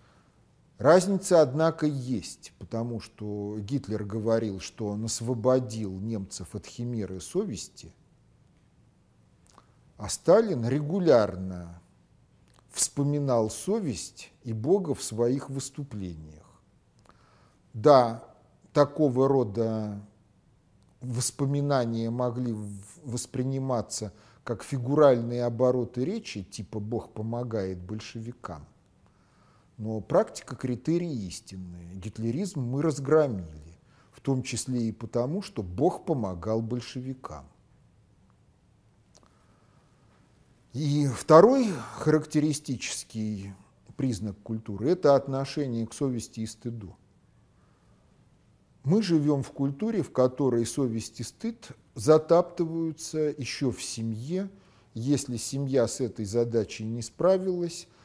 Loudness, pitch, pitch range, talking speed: -28 LUFS, 120 Hz, 110-140 Hz, 90 wpm